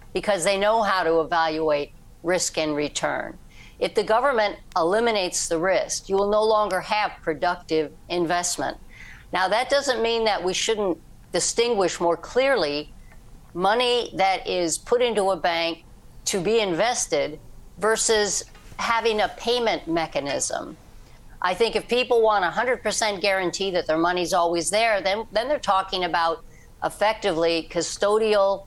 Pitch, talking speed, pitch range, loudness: 190 Hz, 140 wpm, 165-220 Hz, -23 LUFS